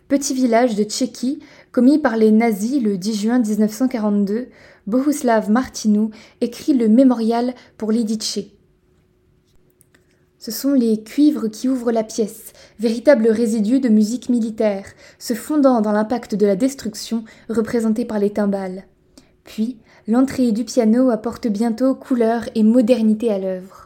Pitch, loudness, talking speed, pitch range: 230 Hz, -18 LUFS, 135 wpm, 215-255 Hz